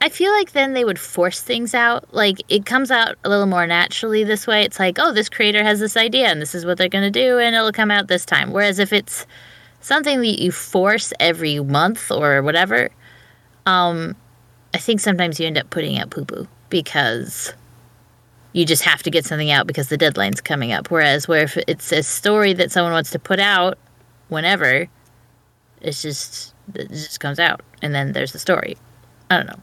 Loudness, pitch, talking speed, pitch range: -17 LUFS, 180 Hz, 210 wpm, 155-215 Hz